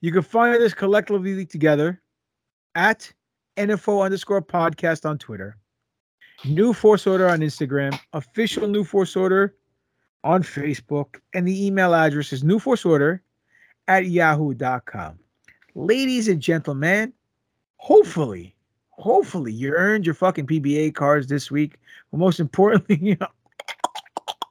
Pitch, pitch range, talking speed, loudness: 170 Hz, 145-195 Hz, 120 wpm, -21 LUFS